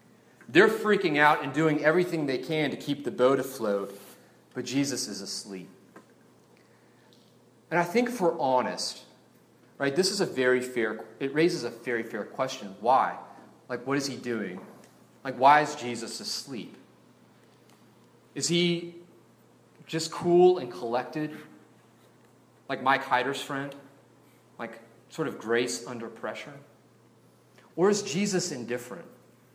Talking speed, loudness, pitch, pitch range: 130 wpm, -27 LUFS, 135 Hz, 120-160 Hz